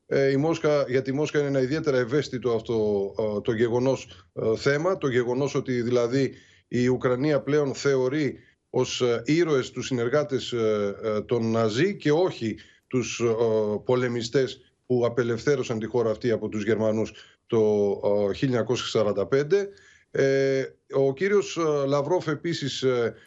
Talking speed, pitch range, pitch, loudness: 115 wpm, 110-140 Hz, 125 Hz, -25 LUFS